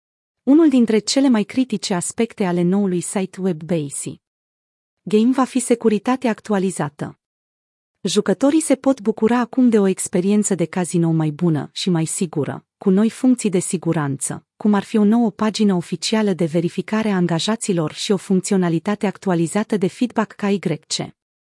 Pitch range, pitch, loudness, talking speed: 170-220 Hz, 195 Hz, -19 LUFS, 150 wpm